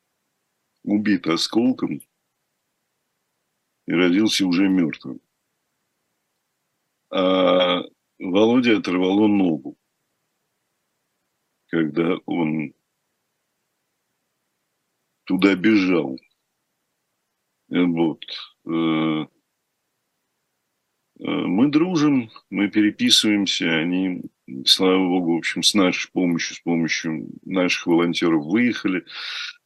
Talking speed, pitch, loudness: 65 wpm, 100 Hz, -20 LUFS